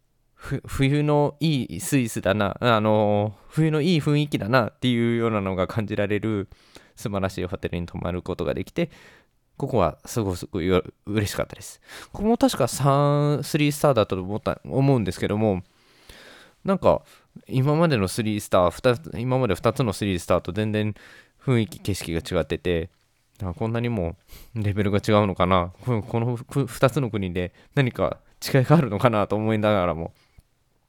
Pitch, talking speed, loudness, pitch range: 110 Hz, 330 characters per minute, -24 LUFS, 95-135 Hz